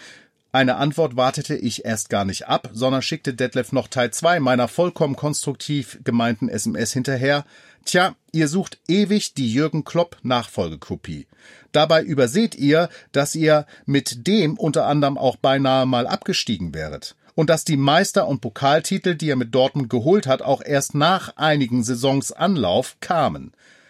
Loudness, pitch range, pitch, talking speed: -20 LUFS, 125-160 Hz, 140 Hz, 155 wpm